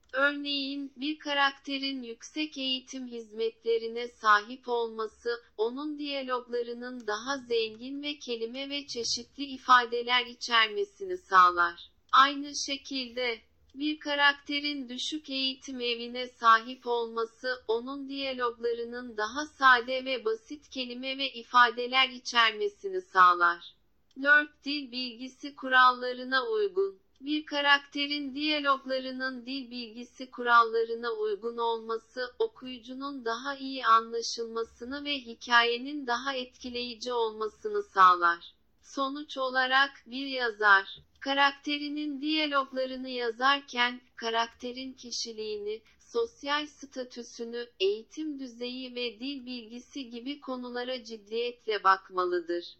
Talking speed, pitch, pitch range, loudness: 95 wpm, 255 Hz, 235-280 Hz, -29 LUFS